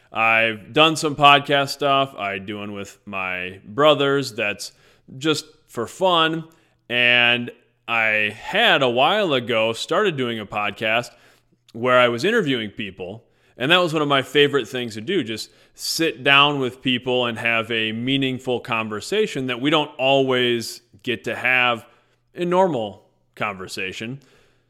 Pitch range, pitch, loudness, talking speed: 115-140 Hz, 125 Hz, -19 LUFS, 145 wpm